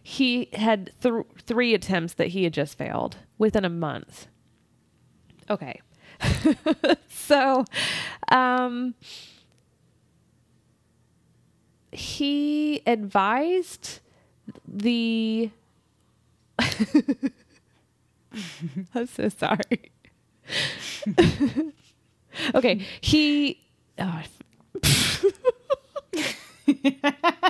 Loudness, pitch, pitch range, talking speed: -25 LUFS, 250 Hz, 205-290 Hz, 55 wpm